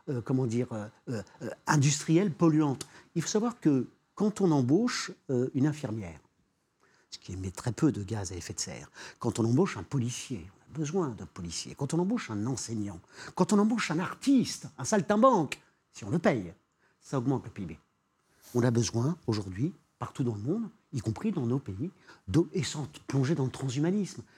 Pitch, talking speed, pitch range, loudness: 135 Hz, 190 wpm, 115-170 Hz, -30 LUFS